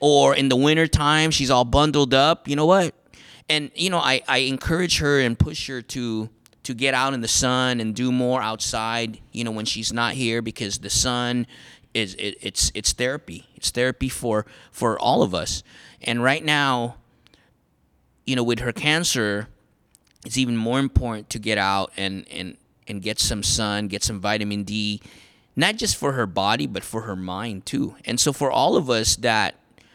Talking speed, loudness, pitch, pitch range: 190 wpm, -22 LUFS, 120 Hz, 105-135 Hz